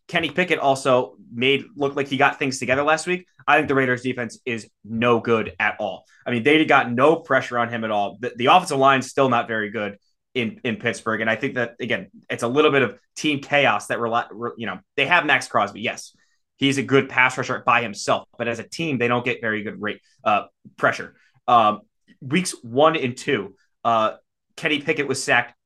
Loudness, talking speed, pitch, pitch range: -21 LUFS, 220 wpm, 130 Hz, 120-145 Hz